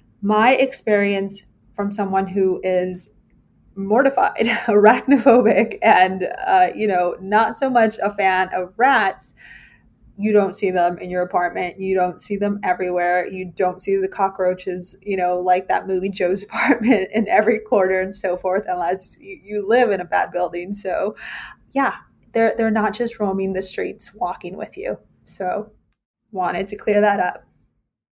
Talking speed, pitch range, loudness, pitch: 160 wpm, 185-220 Hz, -19 LUFS, 195 Hz